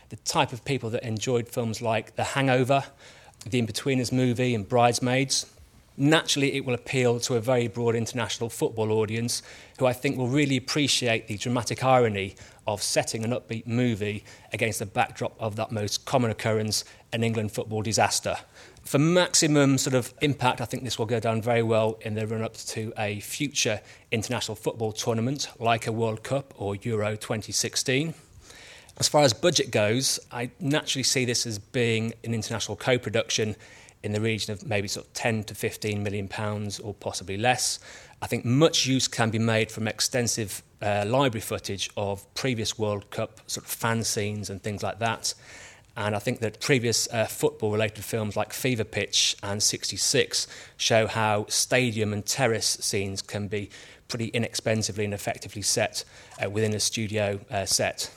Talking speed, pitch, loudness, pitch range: 175 wpm, 115 Hz, -26 LUFS, 105-125 Hz